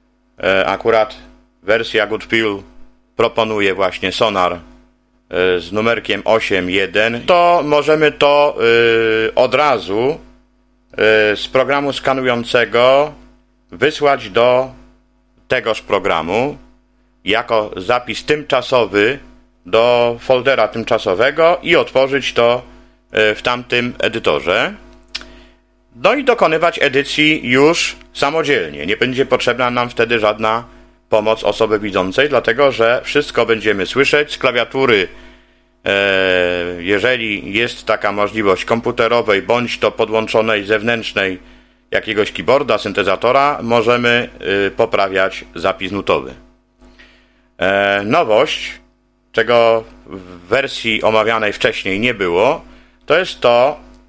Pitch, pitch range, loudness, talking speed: 115 Hz, 105-125 Hz, -15 LUFS, 95 wpm